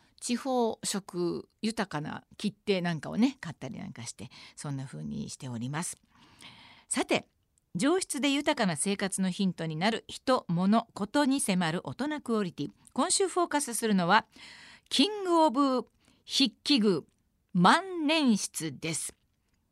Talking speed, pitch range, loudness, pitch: 270 characters per minute, 175-270 Hz, -29 LUFS, 210 Hz